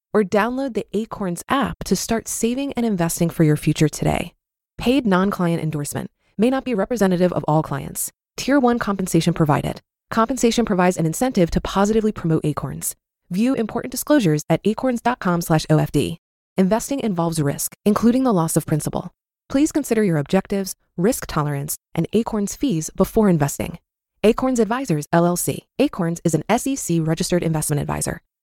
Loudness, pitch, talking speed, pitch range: -20 LUFS, 185 Hz, 150 wpm, 160-225 Hz